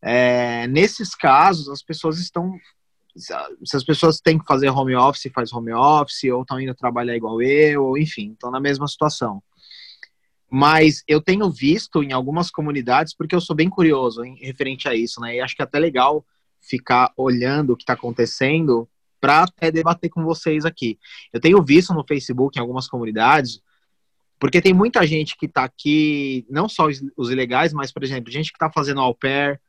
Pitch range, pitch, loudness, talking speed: 125-160 Hz, 140 Hz, -19 LUFS, 185 wpm